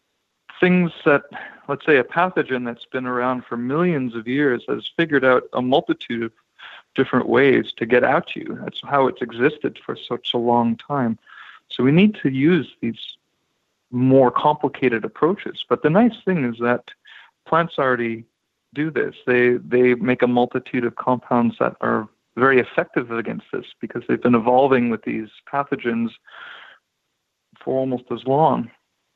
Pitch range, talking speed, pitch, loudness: 120-140 Hz, 160 wpm, 125 Hz, -20 LUFS